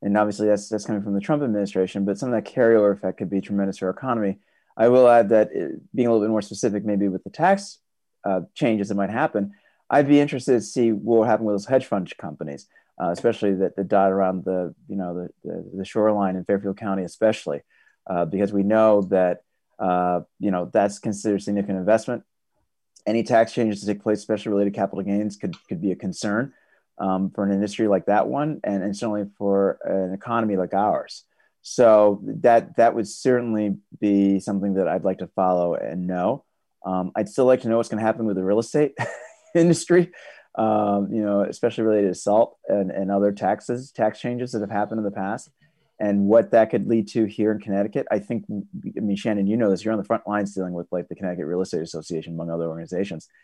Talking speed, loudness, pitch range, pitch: 215 wpm, -22 LUFS, 95-115 Hz, 105 Hz